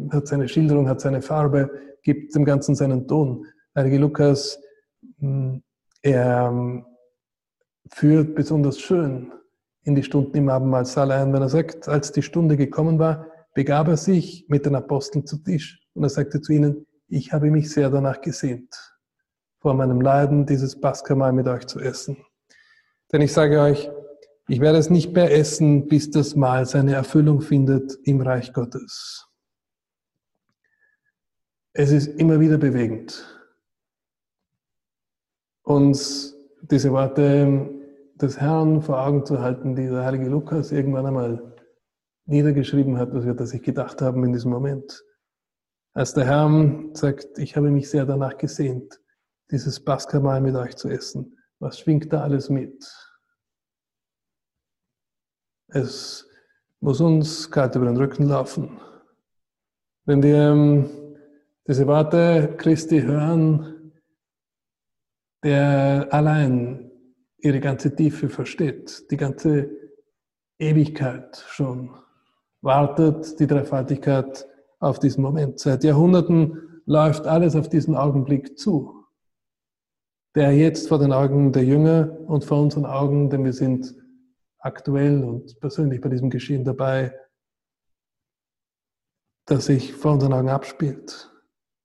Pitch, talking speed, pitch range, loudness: 145 Hz, 125 wpm, 135-155 Hz, -20 LUFS